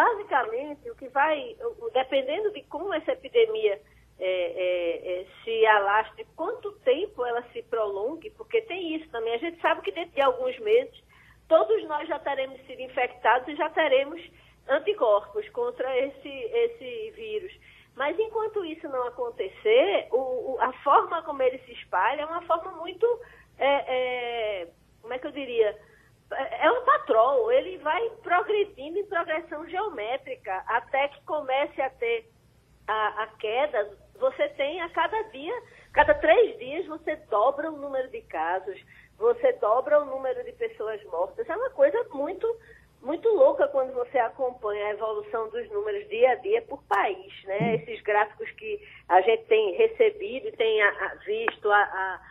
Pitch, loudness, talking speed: 320 Hz, -27 LUFS, 155 wpm